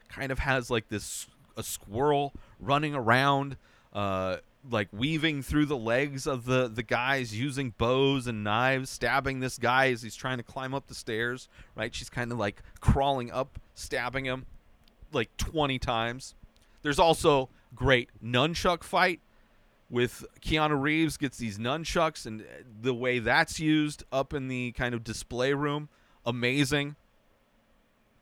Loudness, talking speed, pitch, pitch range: -29 LUFS, 150 wpm, 130 Hz, 115-140 Hz